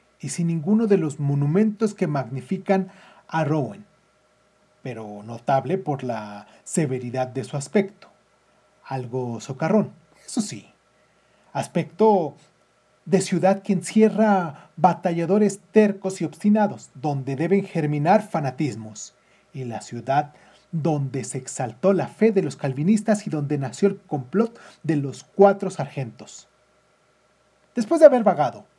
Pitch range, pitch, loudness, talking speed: 135-195 Hz, 165 Hz, -23 LUFS, 125 wpm